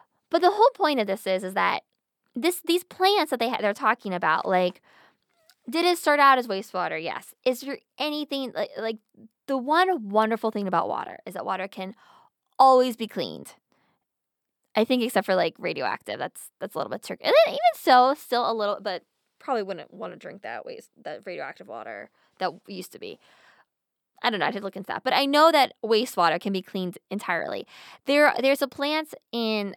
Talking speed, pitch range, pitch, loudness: 200 wpm, 205-295 Hz, 240 Hz, -24 LUFS